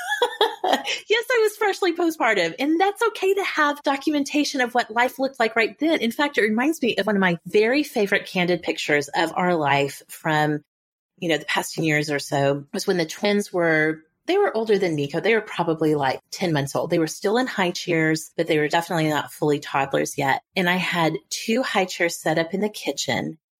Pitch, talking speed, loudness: 190 Hz, 215 wpm, -22 LUFS